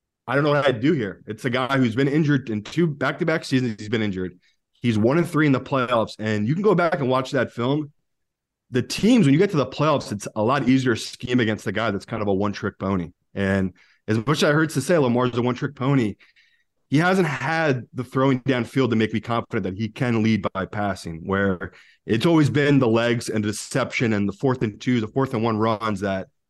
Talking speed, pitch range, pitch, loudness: 240 wpm, 105-140 Hz, 125 Hz, -22 LUFS